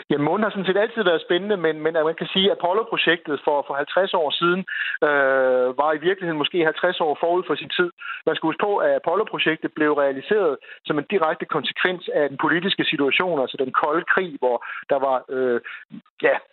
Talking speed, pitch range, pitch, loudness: 205 wpm, 145-190 Hz, 160 Hz, -21 LUFS